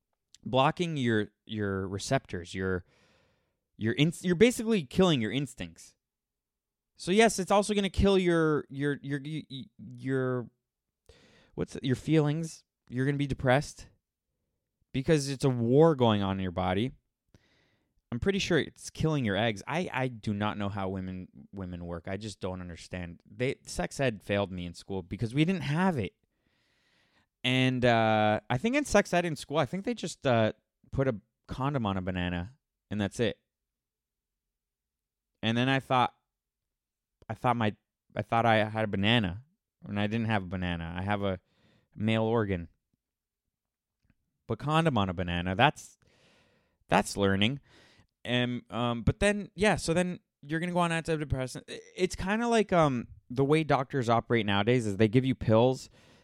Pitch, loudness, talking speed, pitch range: 120 Hz, -29 LUFS, 165 wpm, 100-150 Hz